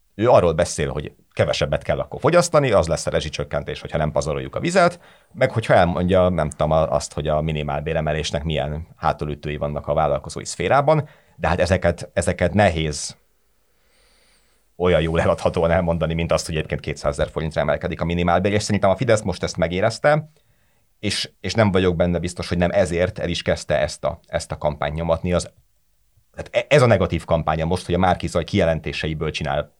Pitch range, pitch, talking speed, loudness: 80-100 Hz, 85 Hz, 180 wpm, -21 LUFS